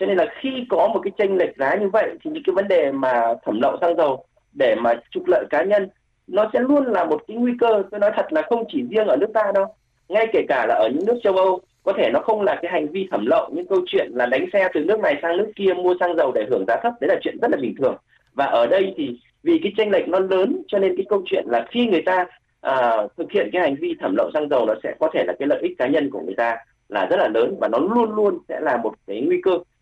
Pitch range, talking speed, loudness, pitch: 185-265 Hz, 300 wpm, -20 LUFS, 205 Hz